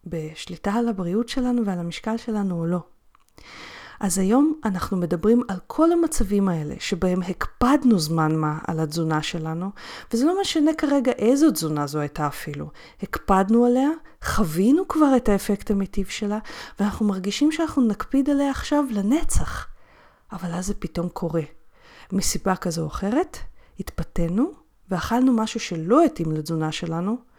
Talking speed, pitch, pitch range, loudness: 140 wpm, 205 Hz, 175-245 Hz, -23 LUFS